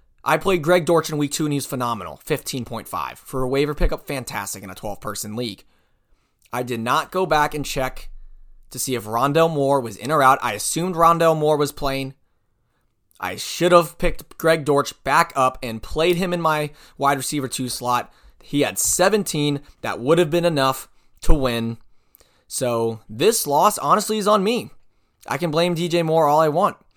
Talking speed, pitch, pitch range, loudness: 190 wpm, 140 Hz, 120-165 Hz, -21 LUFS